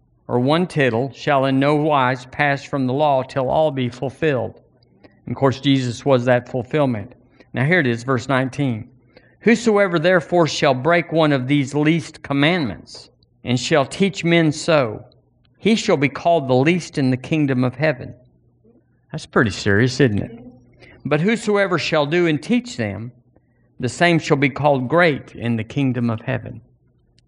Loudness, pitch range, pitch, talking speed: -19 LUFS, 125-155 Hz, 135 Hz, 165 wpm